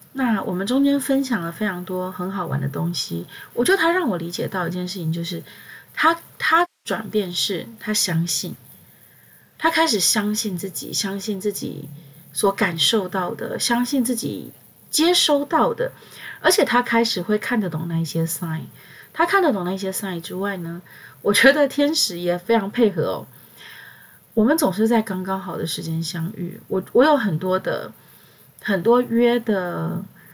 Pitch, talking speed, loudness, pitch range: 195 Hz, 250 characters per minute, -21 LUFS, 175-240 Hz